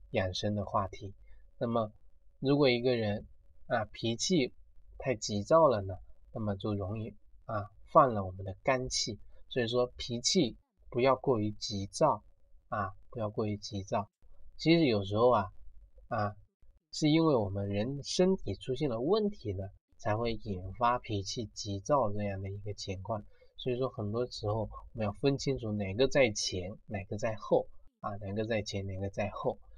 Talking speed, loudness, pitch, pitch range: 235 characters per minute, -32 LUFS, 105 Hz, 100-125 Hz